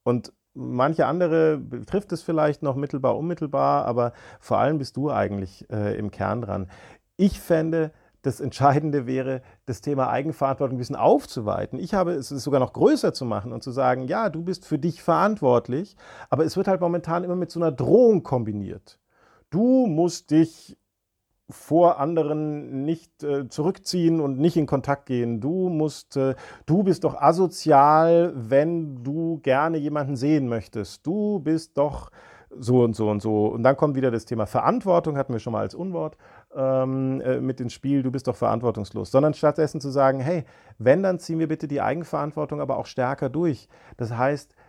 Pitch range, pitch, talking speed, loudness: 125-165 Hz, 145 Hz, 180 wpm, -23 LUFS